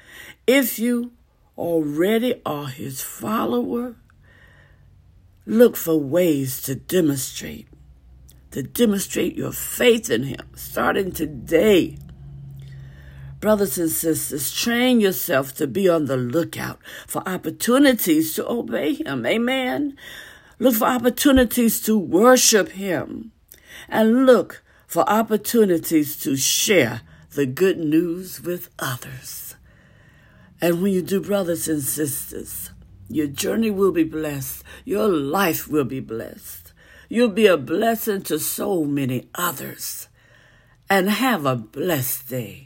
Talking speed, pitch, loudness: 115 wpm, 165 Hz, -20 LUFS